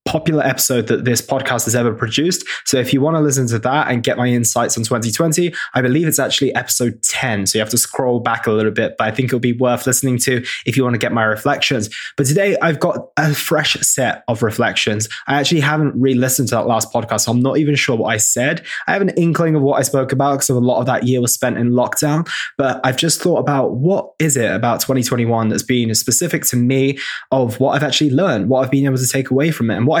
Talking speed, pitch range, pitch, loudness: 260 wpm, 120-140 Hz, 130 Hz, -16 LUFS